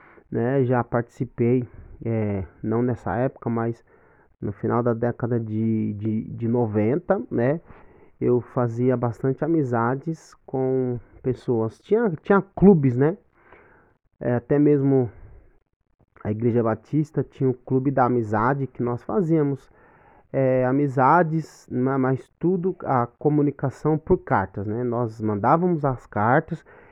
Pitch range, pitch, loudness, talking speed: 115-145 Hz, 125 Hz, -23 LUFS, 120 wpm